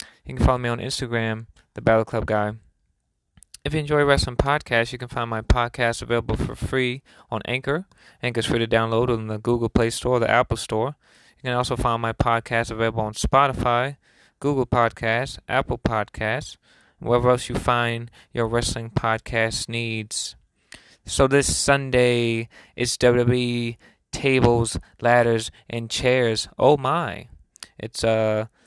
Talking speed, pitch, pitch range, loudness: 155 wpm, 120 Hz, 110-125 Hz, -22 LUFS